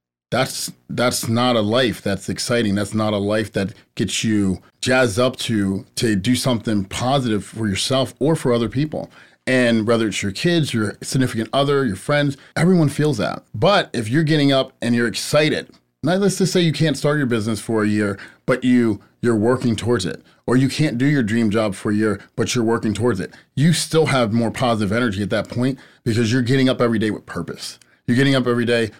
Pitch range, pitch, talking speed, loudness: 110-135 Hz, 120 Hz, 215 wpm, -19 LUFS